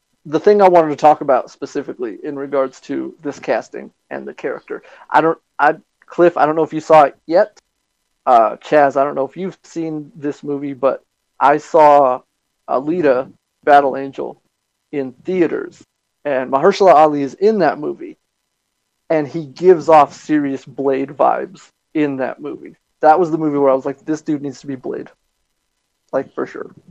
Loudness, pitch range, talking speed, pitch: -16 LUFS, 135-160 Hz, 180 wpm, 145 Hz